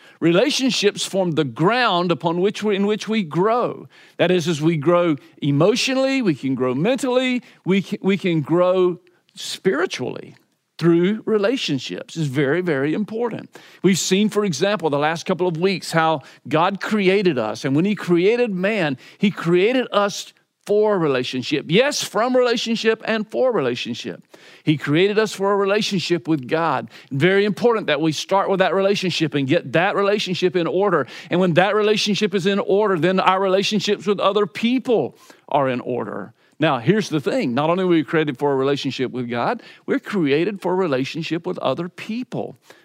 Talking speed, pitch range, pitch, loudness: 170 wpm, 160-205 Hz, 185 Hz, -20 LUFS